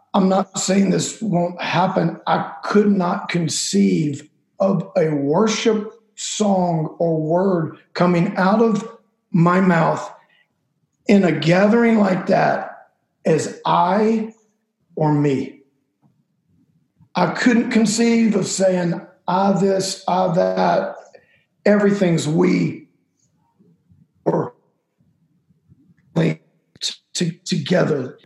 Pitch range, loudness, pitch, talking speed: 170-210 Hz, -19 LUFS, 190 Hz, 95 wpm